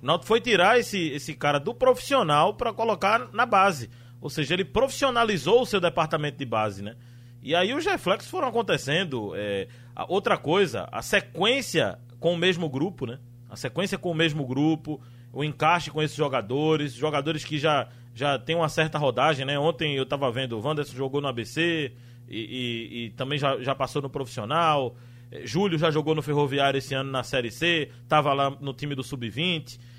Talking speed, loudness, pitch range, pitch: 190 wpm, -25 LUFS, 125-165 Hz, 145 Hz